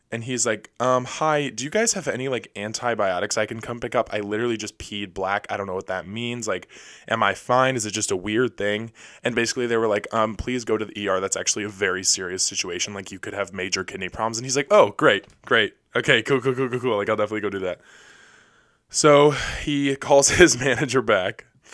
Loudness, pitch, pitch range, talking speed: -22 LUFS, 115 Hz, 105-130 Hz, 235 wpm